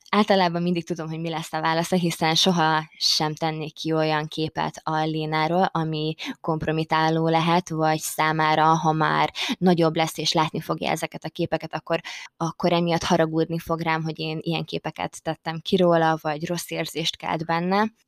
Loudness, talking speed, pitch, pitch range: -23 LUFS, 165 wpm, 160 Hz, 155-170 Hz